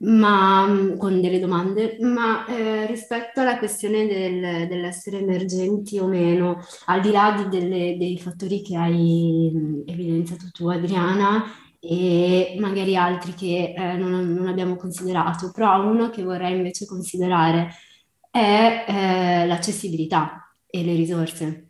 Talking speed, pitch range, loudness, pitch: 130 wpm, 175-200 Hz, -22 LUFS, 185 Hz